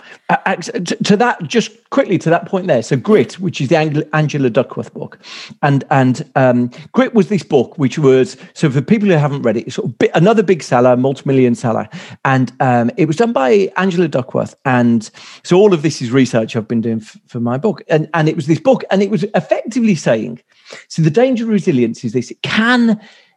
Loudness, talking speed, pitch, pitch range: -14 LUFS, 220 wpm, 160 Hz, 130-205 Hz